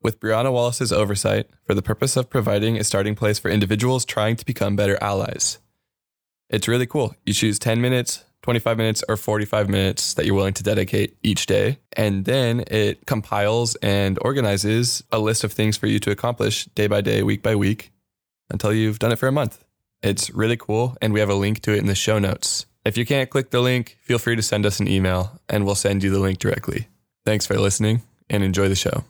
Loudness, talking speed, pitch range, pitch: -21 LUFS, 220 wpm, 100-120 Hz, 110 Hz